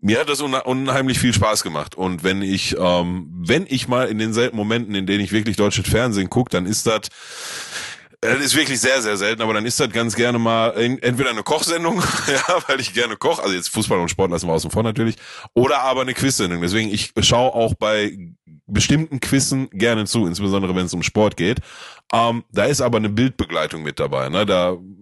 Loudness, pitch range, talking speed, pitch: -19 LUFS, 100-125 Hz, 205 wpm, 110 Hz